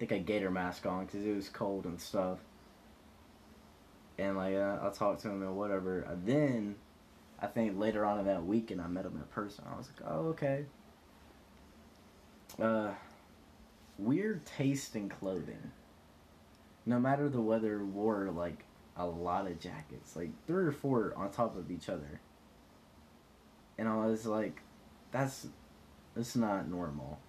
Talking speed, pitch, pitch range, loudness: 160 wpm, 100 Hz, 90-115 Hz, -37 LUFS